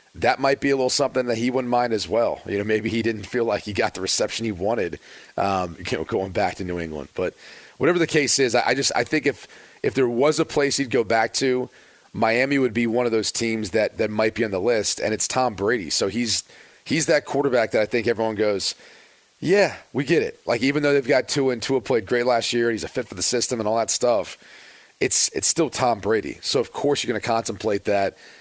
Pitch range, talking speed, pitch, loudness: 110-130 Hz, 255 wpm, 115 Hz, -22 LUFS